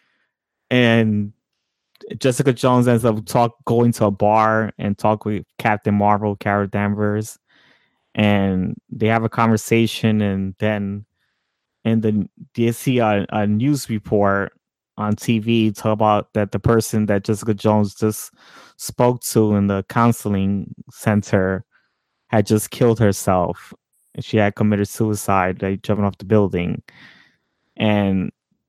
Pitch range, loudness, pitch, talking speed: 100-115 Hz, -19 LUFS, 105 Hz, 135 wpm